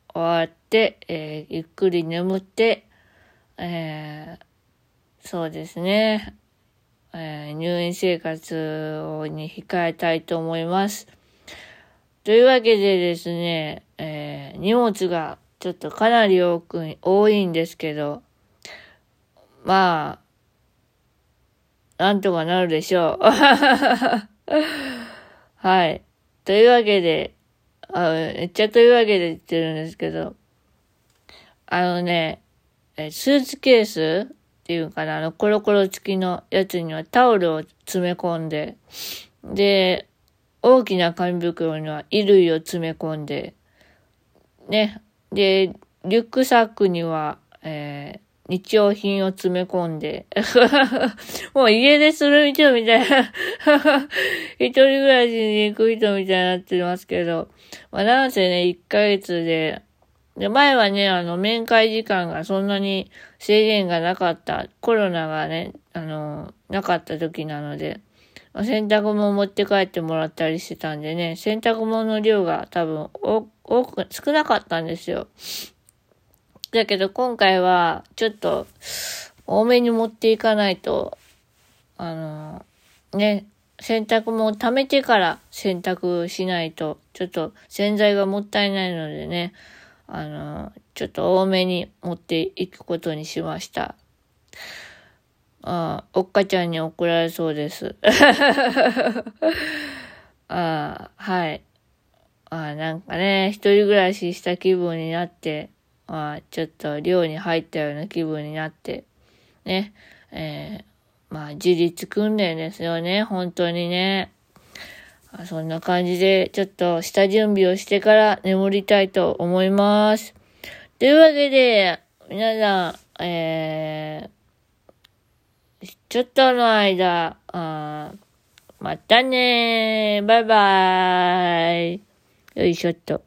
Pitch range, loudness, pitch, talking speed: 165-215 Hz, -20 LUFS, 185 Hz, 225 characters per minute